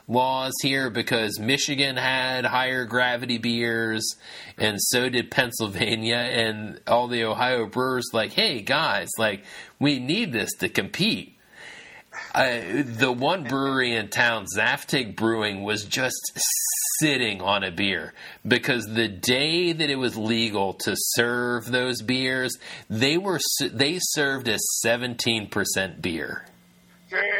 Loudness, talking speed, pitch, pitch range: -23 LUFS, 130 wpm, 120 Hz, 110-130 Hz